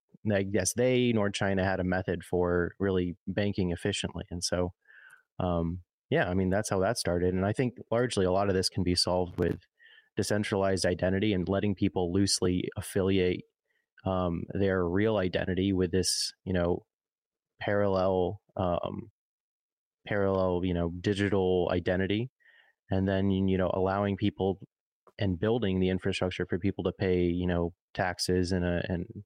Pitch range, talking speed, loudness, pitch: 90-100 Hz, 155 wpm, -29 LUFS, 95 Hz